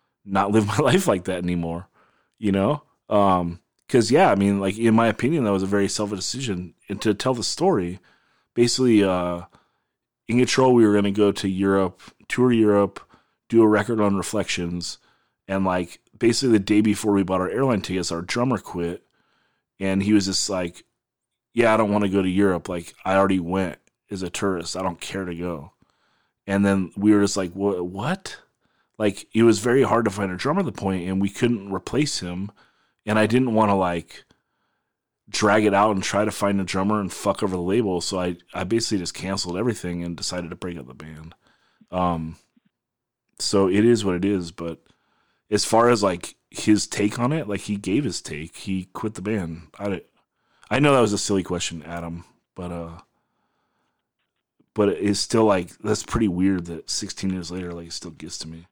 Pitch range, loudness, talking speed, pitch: 90-105 Hz, -22 LUFS, 200 wpm, 100 Hz